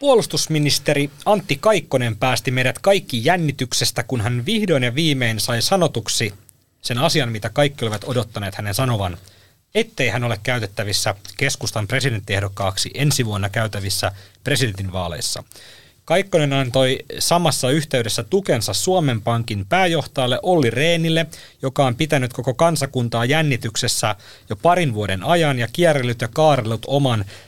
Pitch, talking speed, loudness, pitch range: 130 Hz, 125 wpm, -19 LUFS, 115-150 Hz